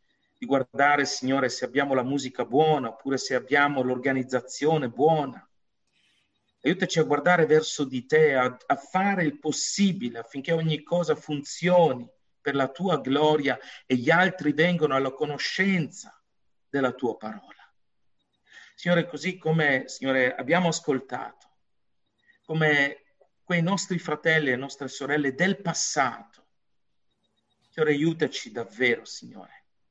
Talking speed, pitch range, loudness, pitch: 120 wpm, 135-160 Hz, -25 LUFS, 150 Hz